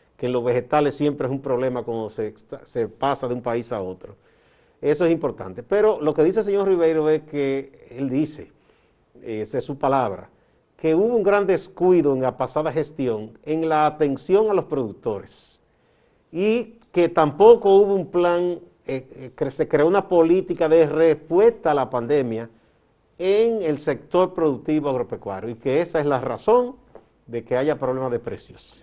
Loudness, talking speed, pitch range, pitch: -21 LUFS, 175 wpm, 130-180 Hz, 155 Hz